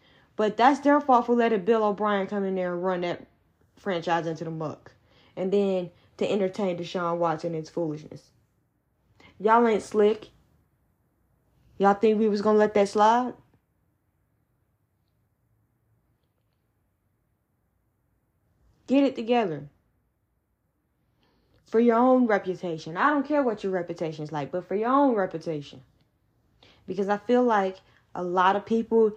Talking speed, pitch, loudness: 135 wpm, 175 Hz, -25 LUFS